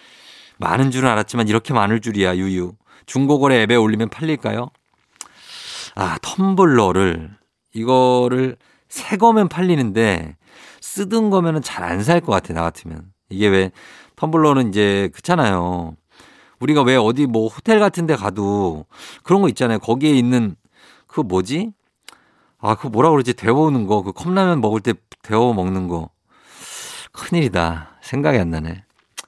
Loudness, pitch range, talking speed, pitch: -18 LUFS, 95-150 Hz, 280 characters per minute, 115 Hz